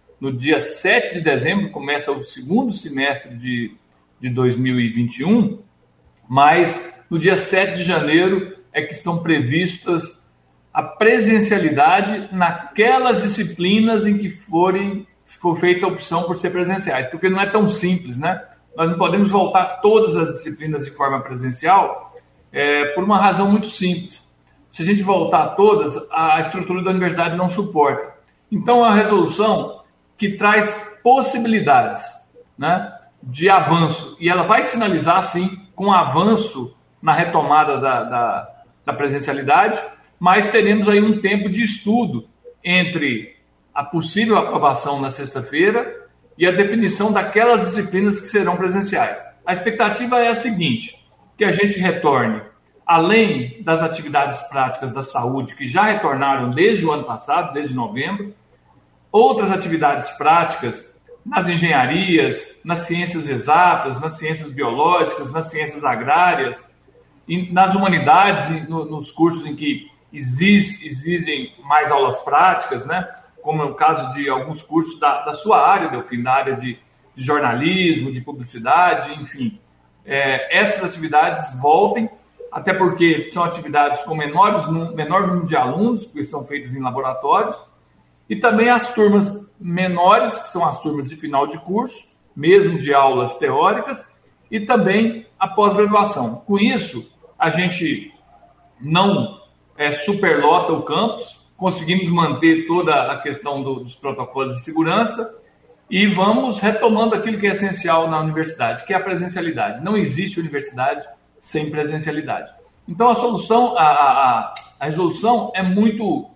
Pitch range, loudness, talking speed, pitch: 150-205 Hz, -18 LUFS, 135 wpm, 175 Hz